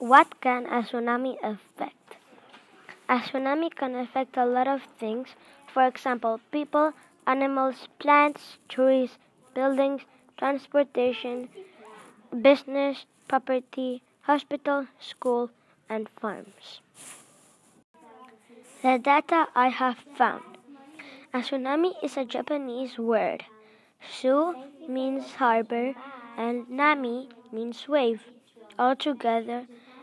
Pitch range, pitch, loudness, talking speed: 245-280 Hz, 260 Hz, -27 LUFS, 90 wpm